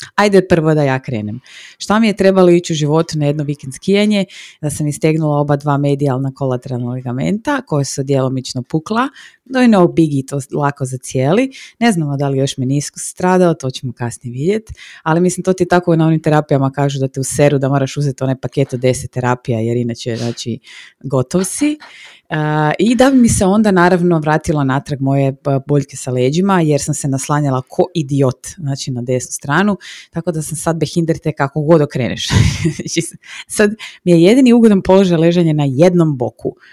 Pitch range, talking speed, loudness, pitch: 135-175 Hz, 185 wpm, -15 LUFS, 150 Hz